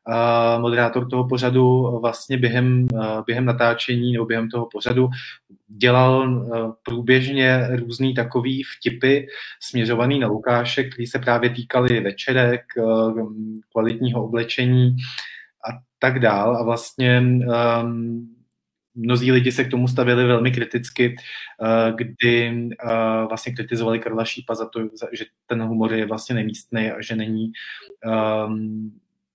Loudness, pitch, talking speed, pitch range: -20 LUFS, 120 Hz, 110 wpm, 115-125 Hz